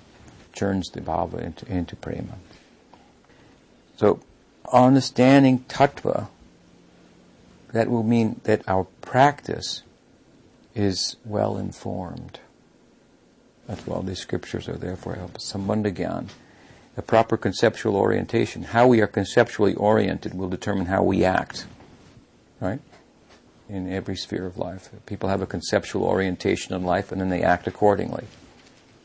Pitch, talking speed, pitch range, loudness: 100 Hz, 120 wpm, 95-115 Hz, -23 LUFS